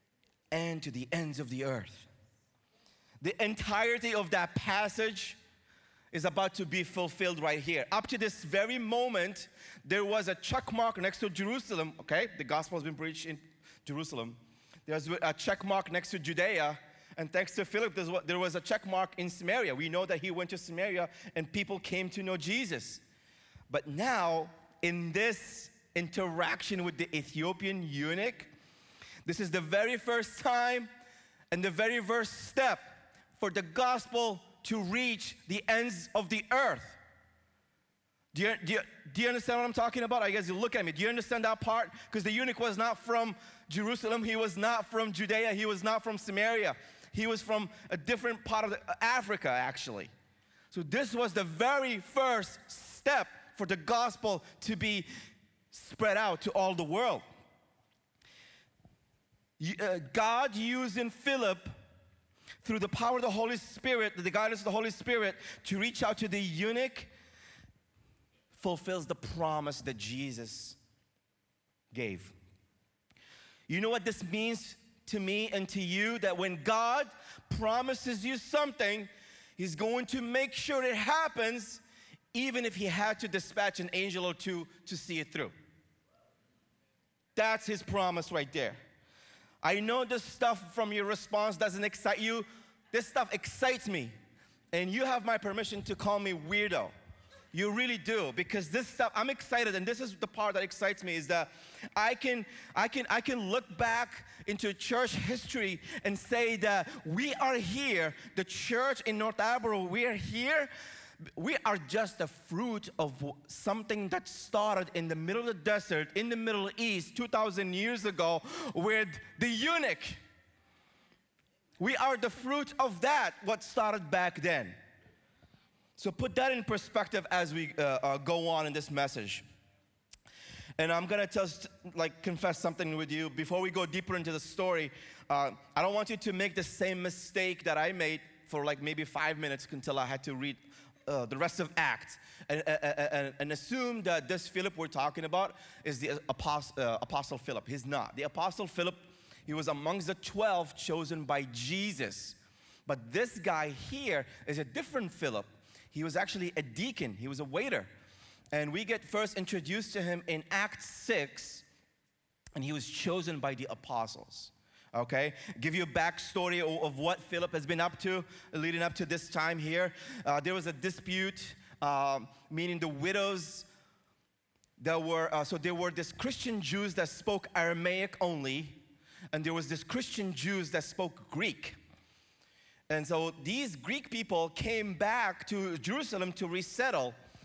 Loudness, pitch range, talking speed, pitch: -34 LUFS, 160-220 Hz, 165 wpm, 190 Hz